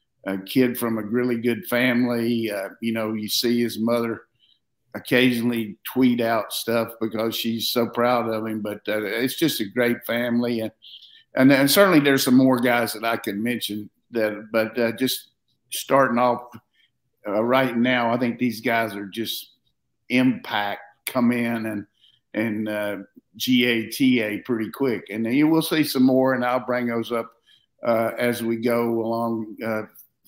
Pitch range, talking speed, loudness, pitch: 110-125 Hz, 170 wpm, -22 LUFS, 115 Hz